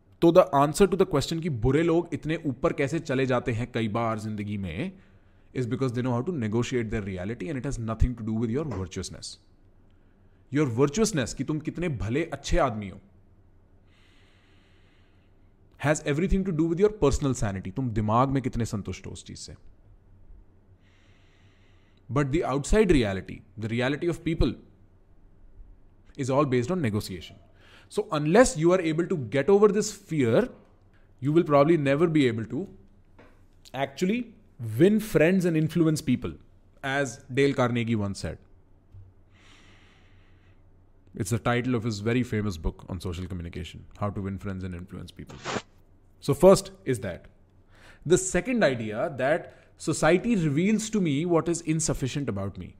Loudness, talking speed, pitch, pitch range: -26 LUFS, 155 wpm, 115 Hz, 95-145 Hz